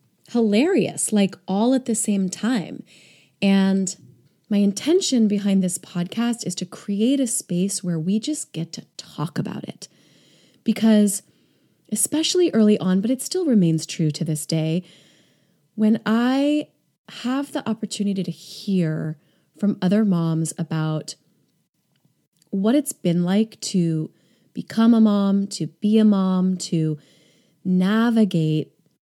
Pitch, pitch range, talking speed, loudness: 200 Hz, 175-225 Hz, 130 wpm, -21 LUFS